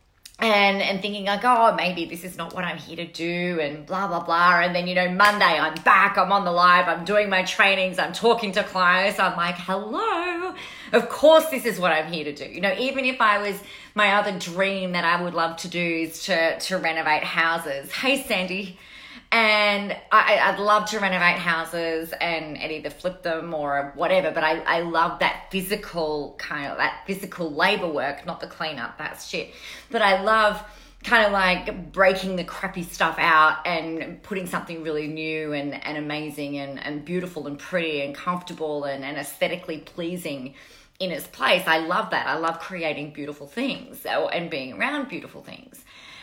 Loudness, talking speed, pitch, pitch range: -22 LUFS, 195 wpm, 180 Hz, 160-200 Hz